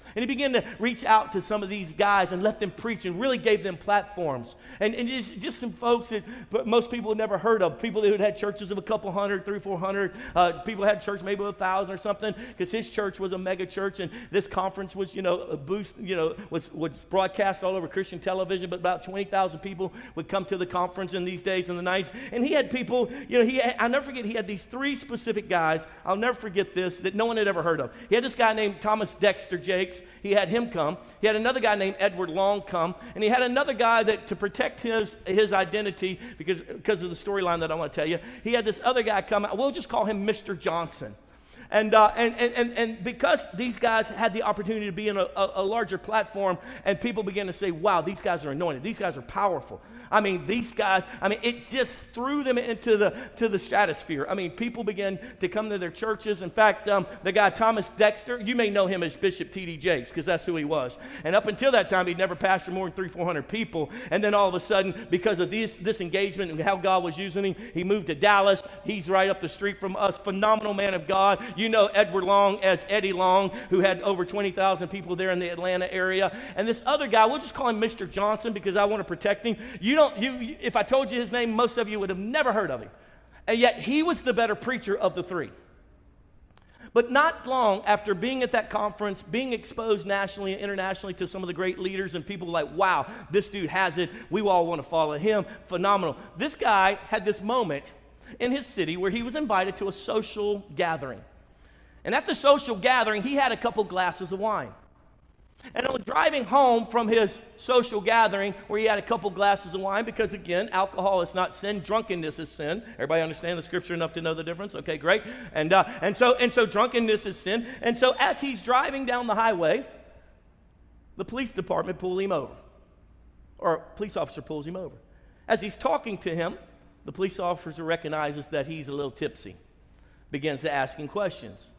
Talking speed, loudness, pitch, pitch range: 230 wpm, -26 LUFS, 200 Hz, 185-225 Hz